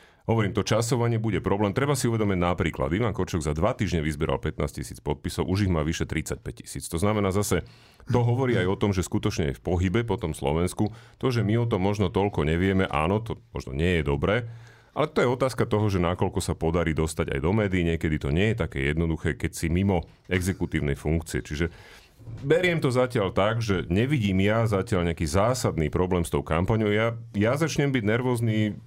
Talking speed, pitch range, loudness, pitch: 205 wpm, 85-115 Hz, -26 LUFS, 95 Hz